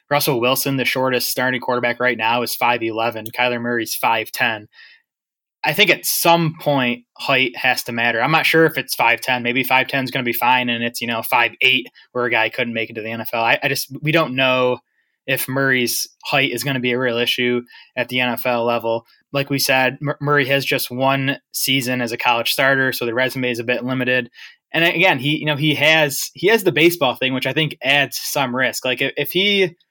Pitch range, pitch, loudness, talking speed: 120-140 Hz, 130 Hz, -18 LUFS, 225 wpm